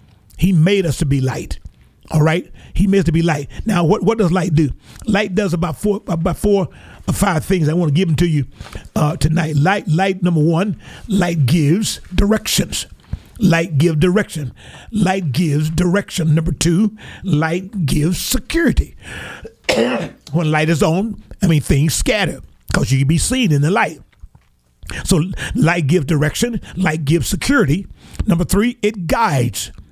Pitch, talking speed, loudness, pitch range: 170 Hz, 165 wpm, -17 LUFS, 155-195 Hz